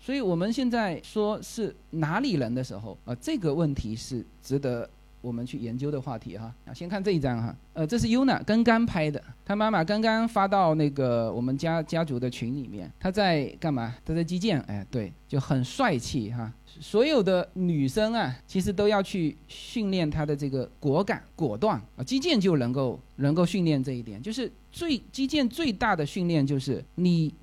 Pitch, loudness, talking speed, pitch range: 155 Hz, -27 LUFS, 285 characters per minute, 130-205 Hz